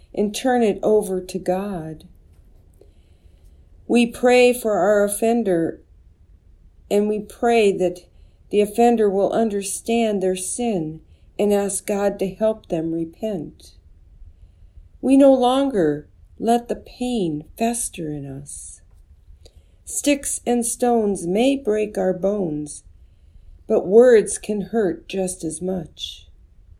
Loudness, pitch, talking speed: -20 LUFS, 185 Hz, 115 wpm